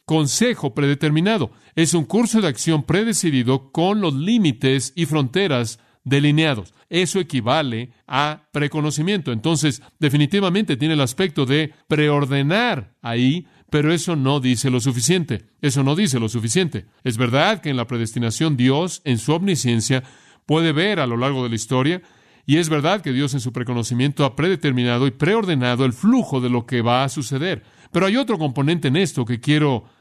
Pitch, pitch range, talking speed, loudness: 145 Hz, 125-165 Hz, 165 wpm, -20 LUFS